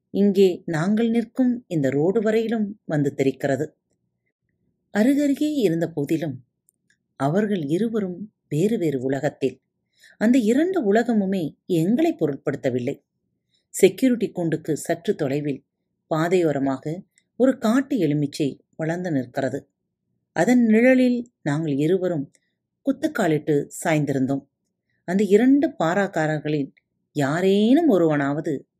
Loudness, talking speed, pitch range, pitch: -22 LUFS, 90 wpm, 140-220 Hz, 165 Hz